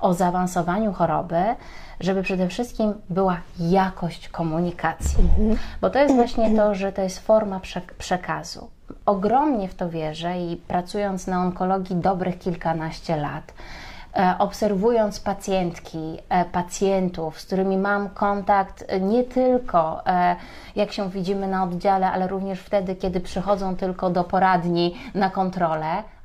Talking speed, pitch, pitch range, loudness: 125 wpm, 190 Hz, 175-200 Hz, -23 LUFS